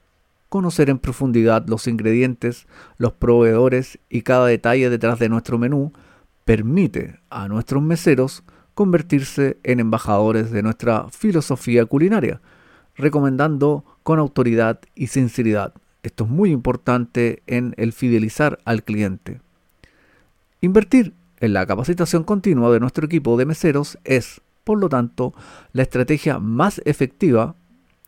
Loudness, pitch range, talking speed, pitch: -19 LUFS, 115-150 Hz, 120 wpm, 125 Hz